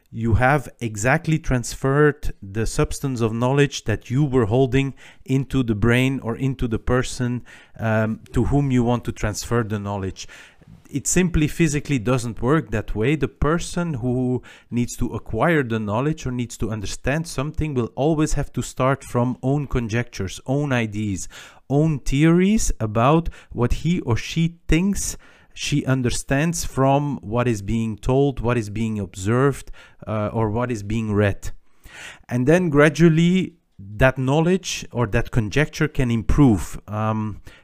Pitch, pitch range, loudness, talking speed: 125 Hz, 110-145 Hz, -22 LUFS, 150 wpm